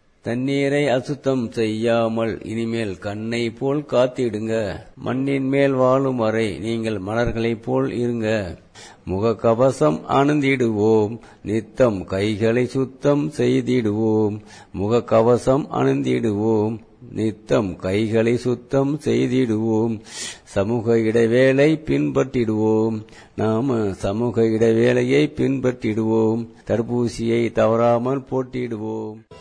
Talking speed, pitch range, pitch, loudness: 75 wpm, 110-130 Hz, 115 Hz, -20 LUFS